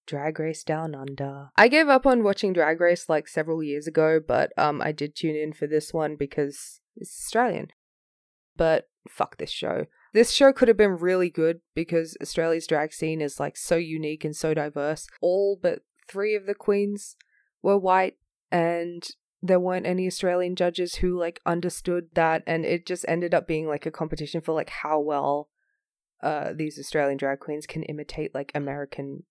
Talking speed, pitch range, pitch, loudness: 180 wpm, 150-185 Hz, 165 Hz, -25 LUFS